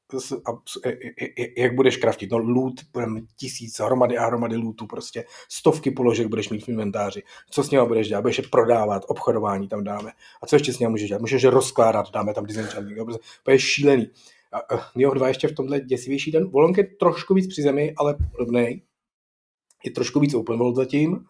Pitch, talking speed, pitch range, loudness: 125 Hz, 185 wpm, 115-135 Hz, -22 LUFS